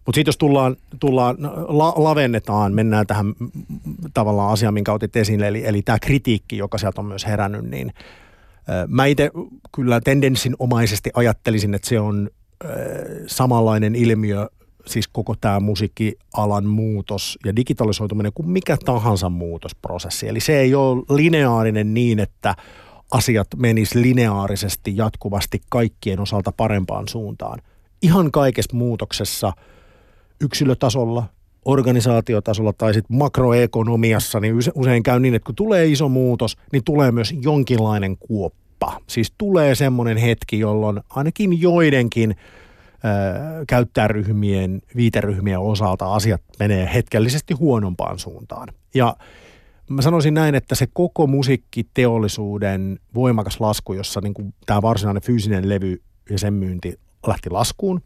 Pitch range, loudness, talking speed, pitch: 105-130 Hz, -19 LUFS, 125 wpm, 110 Hz